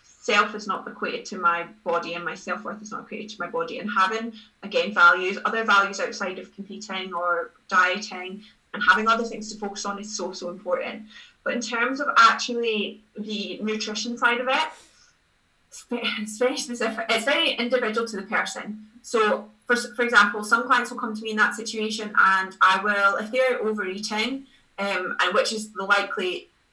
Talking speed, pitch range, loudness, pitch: 190 wpm, 200-240 Hz, -23 LUFS, 215 Hz